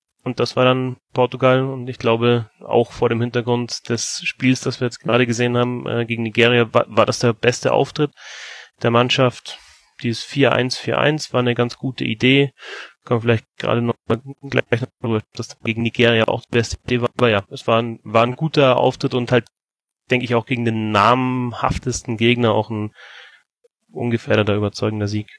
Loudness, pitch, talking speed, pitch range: -19 LUFS, 120 Hz, 180 wpm, 115-130 Hz